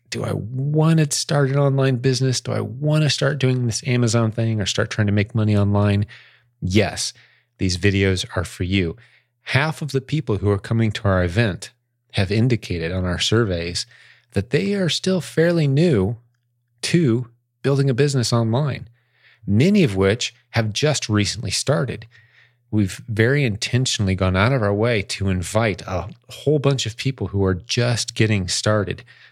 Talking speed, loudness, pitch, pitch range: 170 wpm, -20 LUFS, 115 Hz, 100-135 Hz